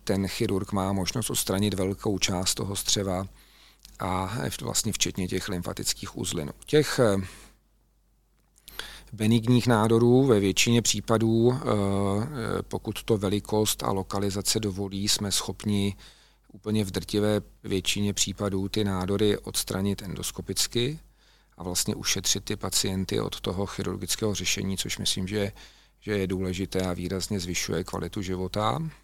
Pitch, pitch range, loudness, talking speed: 100 Hz, 95-105 Hz, -27 LUFS, 120 wpm